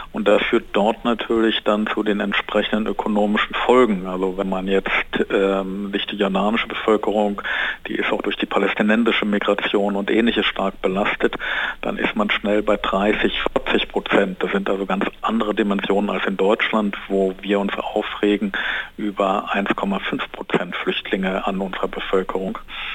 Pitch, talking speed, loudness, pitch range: 100 Hz, 155 wpm, -20 LUFS, 95-105 Hz